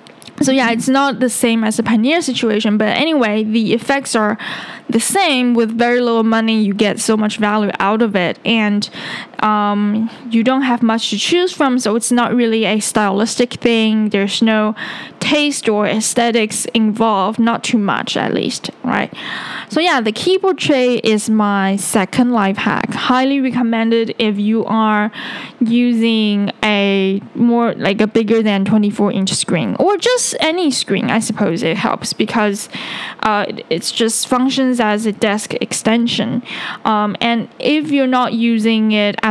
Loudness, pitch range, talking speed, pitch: -15 LUFS, 215-245 Hz, 165 wpm, 225 Hz